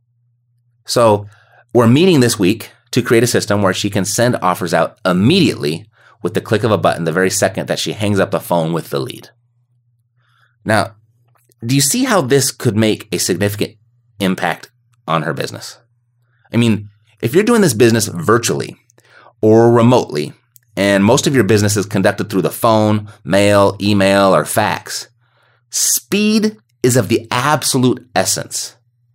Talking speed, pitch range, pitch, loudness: 160 wpm, 100-120 Hz, 115 Hz, -14 LUFS